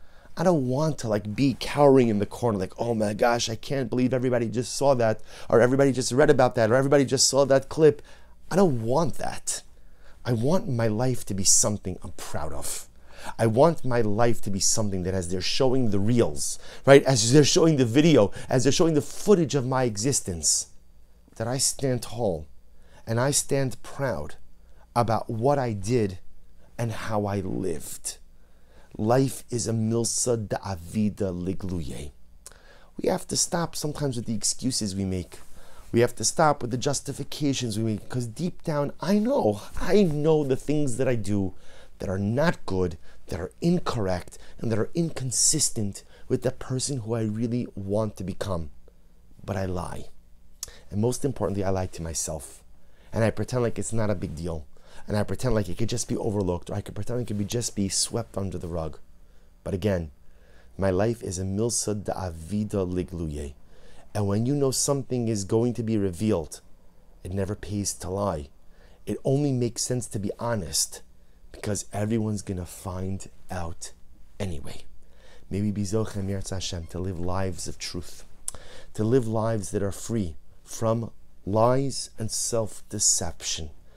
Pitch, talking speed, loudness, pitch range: 105 Hz, 175 wpm, -26 LUFS, 90-125 Hz